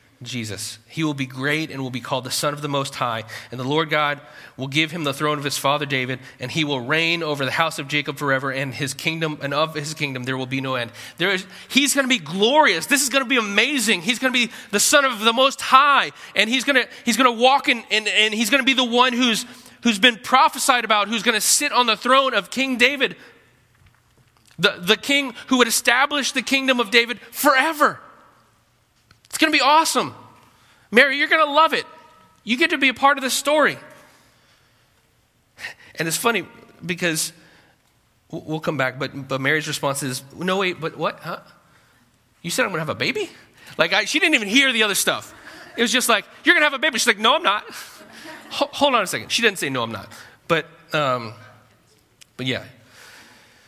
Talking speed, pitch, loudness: 215 wpm, 180 Hz, -19 LUFS